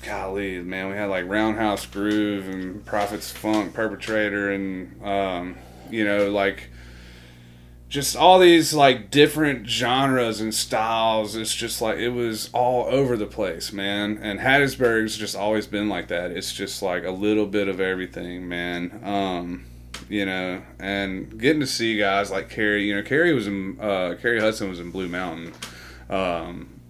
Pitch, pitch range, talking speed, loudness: 100 Hz, 95-110 Hz, 165 wpm, -23 LUFS